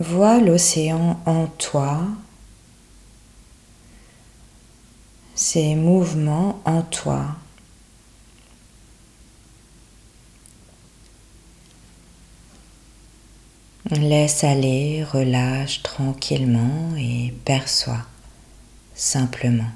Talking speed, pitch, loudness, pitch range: 45 wpm, 150 Hz, -20 LUFS, 130-165 Hz